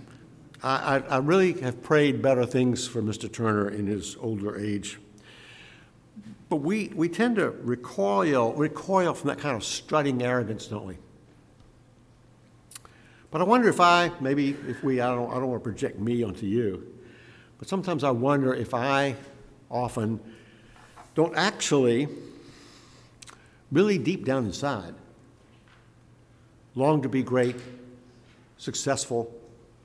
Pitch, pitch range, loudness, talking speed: 125 Hz, 115-140 Hz, -26 LUFS, 130 wpm